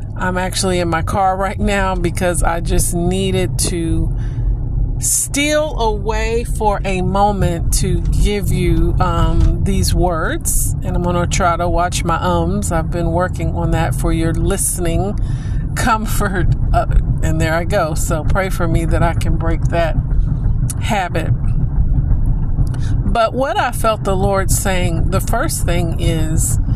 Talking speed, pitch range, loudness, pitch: 150 wpm, 110-150 Hz, -17 LUFS, 120 Hz